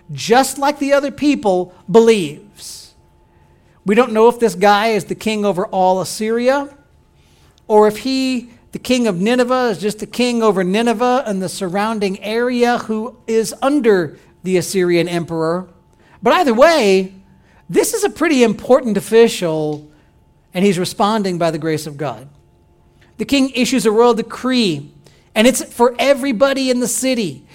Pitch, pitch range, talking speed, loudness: 220 Hz, 185-250 Hz, 155 wpm, -15 LUFS